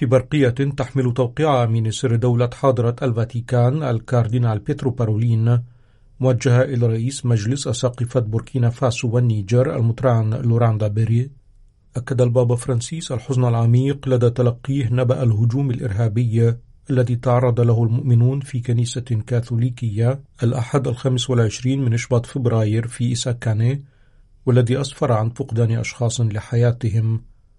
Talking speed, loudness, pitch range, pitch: 115 wpm, -19 LUFS, 115-130 Hz, 120 Hz